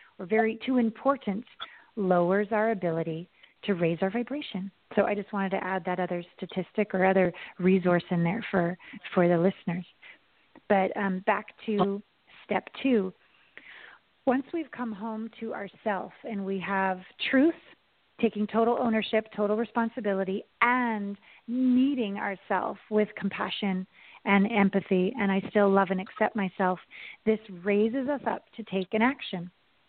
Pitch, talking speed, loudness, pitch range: 205 Hz, 145 wpm, -28 LUFS, 190-225 Hz